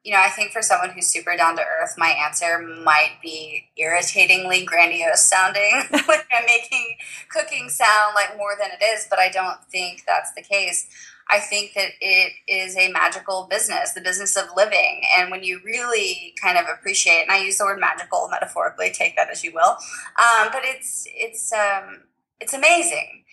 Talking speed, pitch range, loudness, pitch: 190 wpm, 180-230 Hz, -18 LUFS, 195 Hz